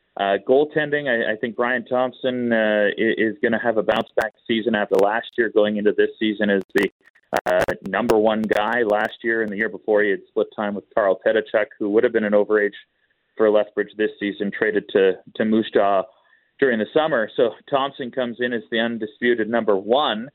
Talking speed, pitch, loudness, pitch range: 205 wpm, 110 Hz, -21 LUFS, 105-125 Hz